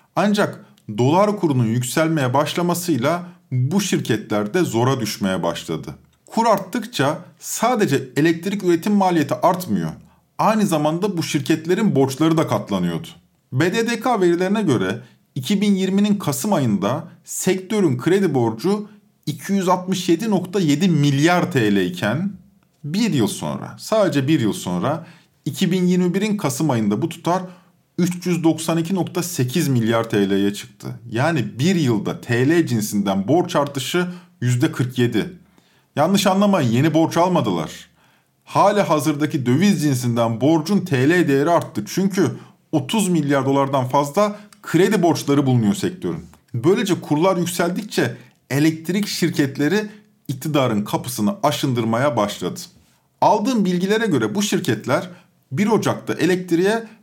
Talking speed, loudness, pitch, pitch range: 105 wpm, -19 LUFS, 165 Hz, 140-190 Hz